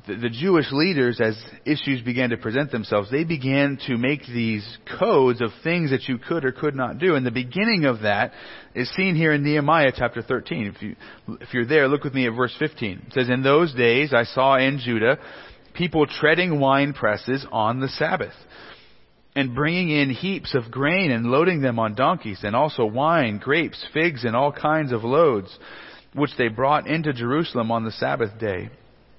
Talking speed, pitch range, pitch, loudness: 190 wpm, 120-150 Hz, 130 Hz, -22 LUFS